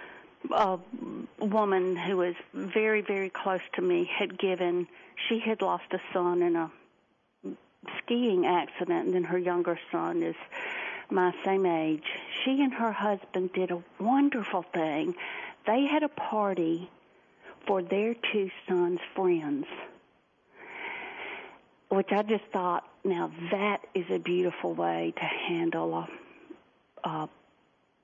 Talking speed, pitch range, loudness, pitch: 130 wpm, 180-255 Hz, -30 LUFS, 195 Hz